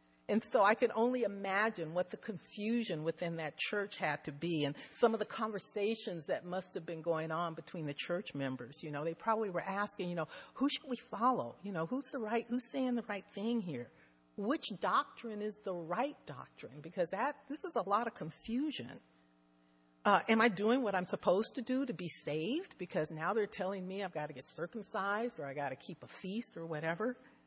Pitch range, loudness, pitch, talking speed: 160-230 Hz, -37 LUFS, 200 Hz, 215 wpm